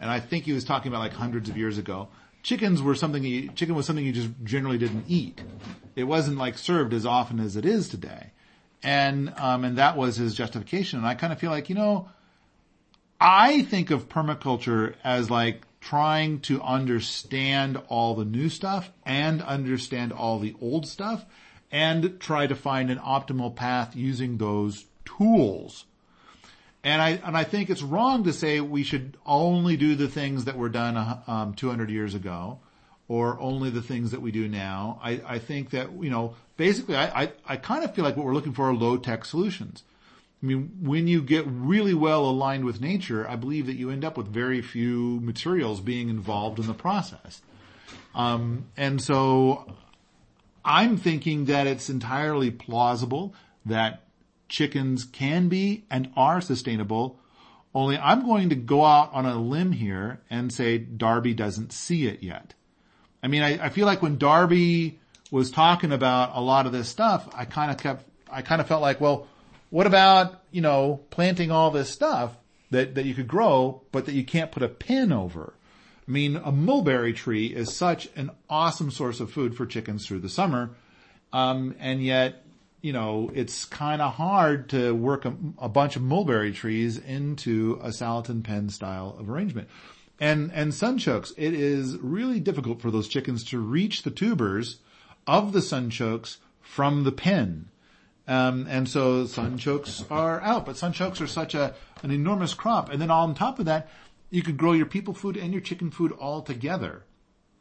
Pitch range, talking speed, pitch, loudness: 120-160 Hz, 185 wpm, 135 Hz, -25 LUFS